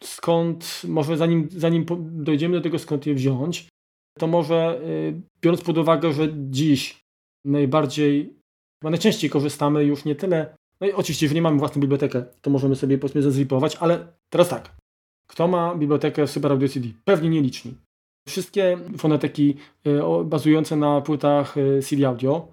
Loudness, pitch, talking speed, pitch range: -22 LUFS, 150 Hz, 150 wpm, 140-165 Hz